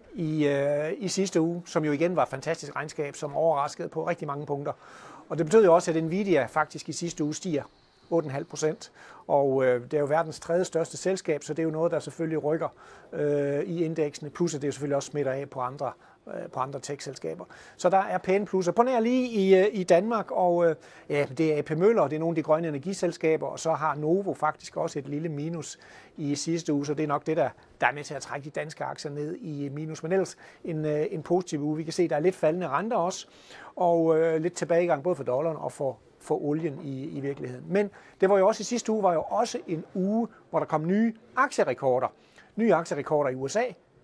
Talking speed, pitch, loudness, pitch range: 230 wpm, 160 Hz, -27 LUFS, 145-175 Hz